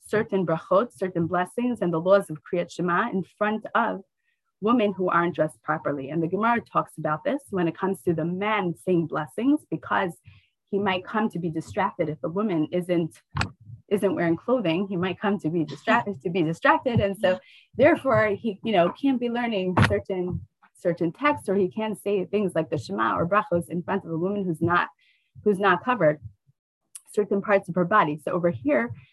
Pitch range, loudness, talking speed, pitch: 170-210 Hz, -25 LUFS, 195 wpm, 185 Hz